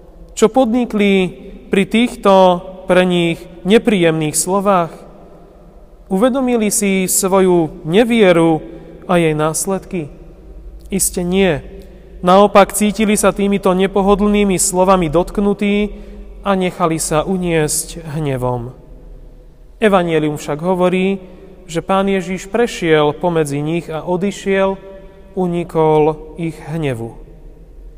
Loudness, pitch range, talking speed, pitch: -15 LUFS, 165-200 Hz, 90 wpm, 185 Hz